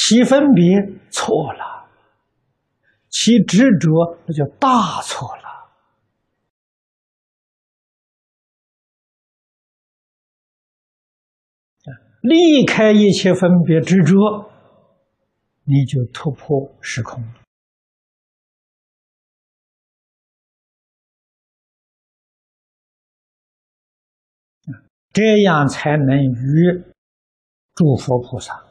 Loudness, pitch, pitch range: -15 LUFS, 170 Hz, 135-210 Hz